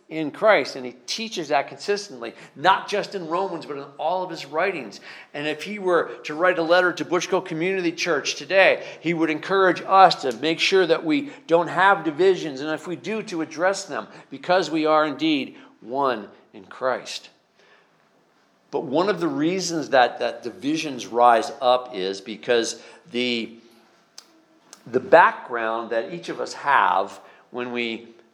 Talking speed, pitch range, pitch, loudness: 165 wpm, 125-185 Hz, 160 Hz, -22 LUFS